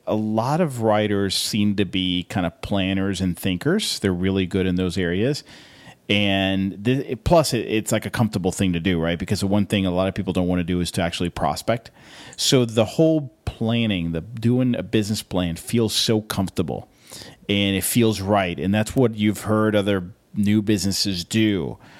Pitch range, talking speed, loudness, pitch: 95-110 Hz, 195 wpm, -22 LUFS, 100 Hz